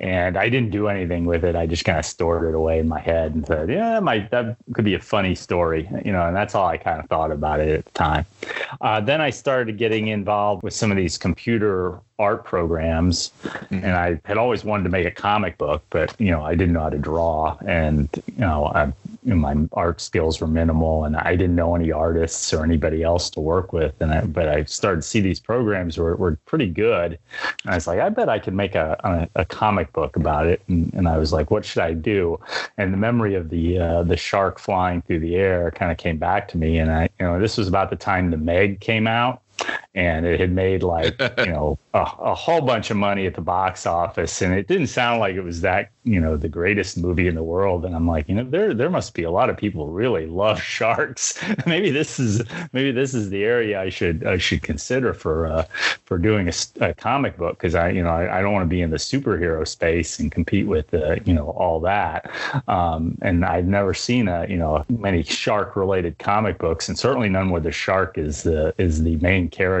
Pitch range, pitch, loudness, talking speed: 80-100 Hz, 90 Hz, -21 LUFS, 245 wpm